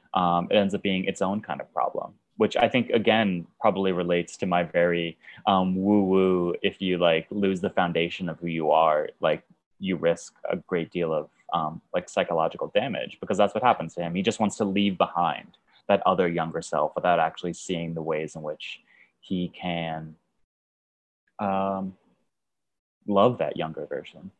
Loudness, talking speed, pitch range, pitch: -26 LUFS, 175 wpm, 85-95 Hz, 90 Hz